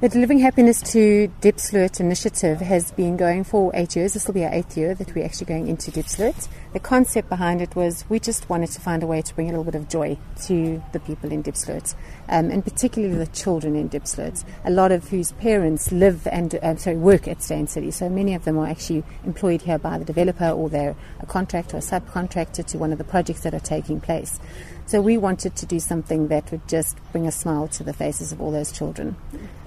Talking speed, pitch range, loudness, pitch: 230 wpm, 155-190 Hz, -22 LUFS, 170 Hz